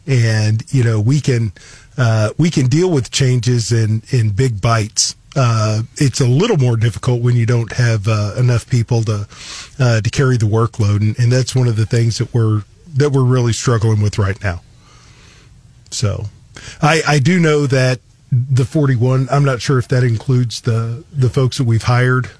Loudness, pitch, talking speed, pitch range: -15 LUFS, 120 Hz, 190 wpm, 110-130 Hz